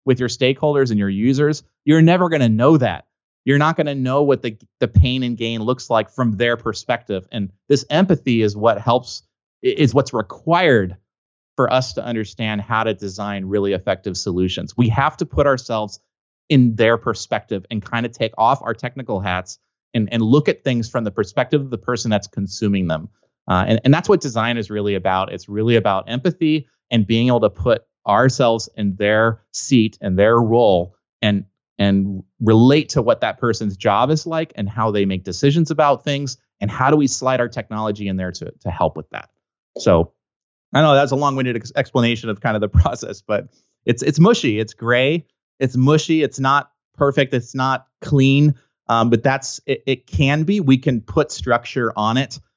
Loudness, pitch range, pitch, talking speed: -18 LUFS, 110-140 Hz, 120 Hz, 200 wpm